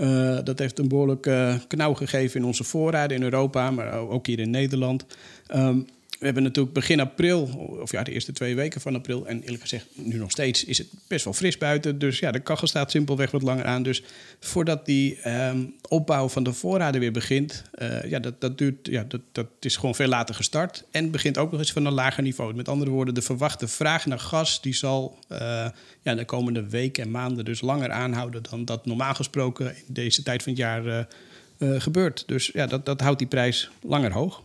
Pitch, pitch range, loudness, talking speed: 130 Hz, 125-145 Hz, -25 LUFS, 220 wpm